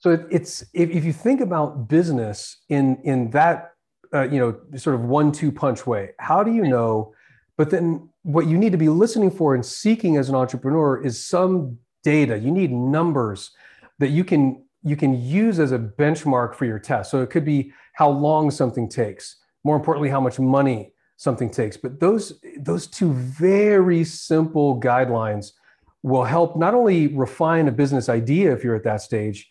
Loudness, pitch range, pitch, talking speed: -20 LUFS, 125-165 Hz, 145 Hz, 185 wpm